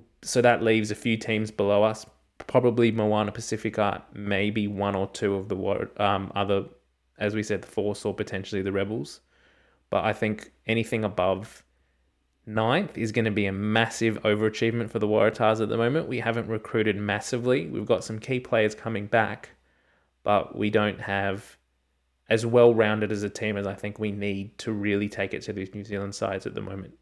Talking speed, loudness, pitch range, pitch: 185 wpm, -26 LUFS, 100-110 Hz, 105 Hz